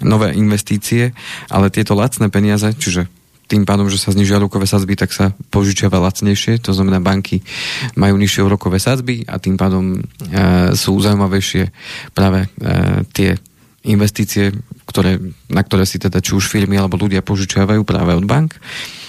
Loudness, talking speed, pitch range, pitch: -15 LUFS, 155 wpm, 95-105 Hz, 100 Hz